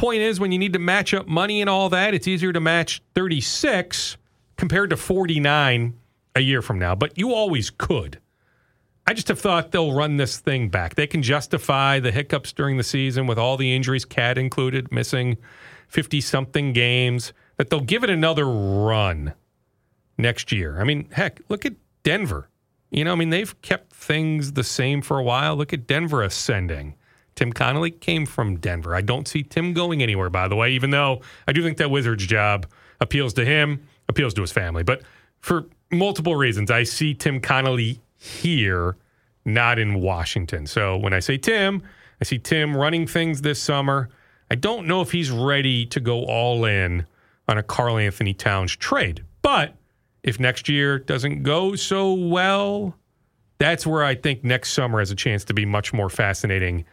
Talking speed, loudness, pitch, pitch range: 185 wpm, -22 LUFS, 135 Hz, 115-155 Hz